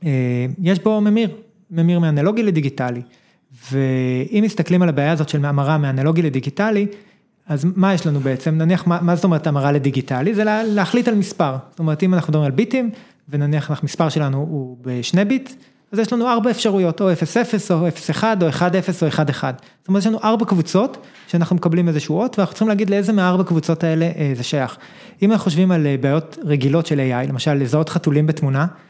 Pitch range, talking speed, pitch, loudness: 145-200 Hz, 185 wpm, 170 Hz, -18 LUFS